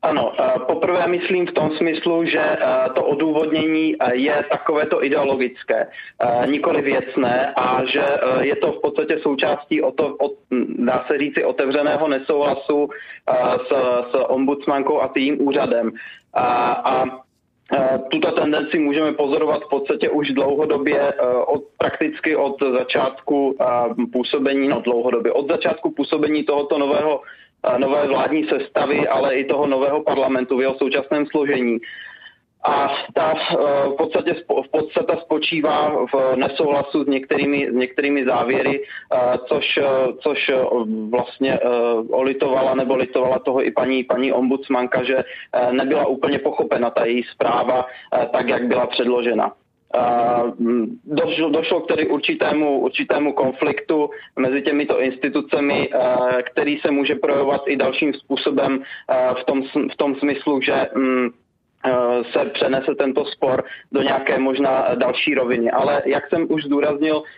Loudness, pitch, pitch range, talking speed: -19 LUFS, 140 Hz, 130-150 Hz, 130 wpm